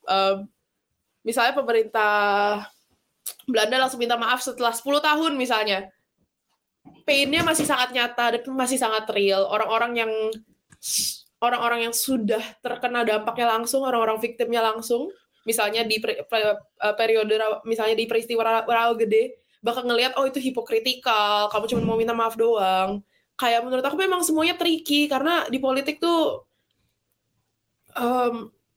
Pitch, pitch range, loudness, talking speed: 235 Hz, 220-260 Hz, -23 LUFS, 125 wpm